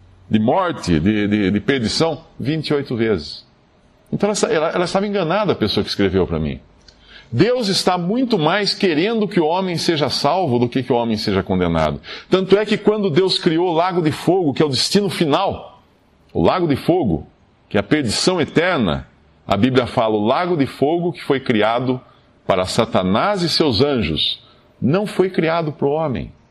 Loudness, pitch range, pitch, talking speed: -18 LUFS, 110-185 Hz, 150 Hz, 185 wpm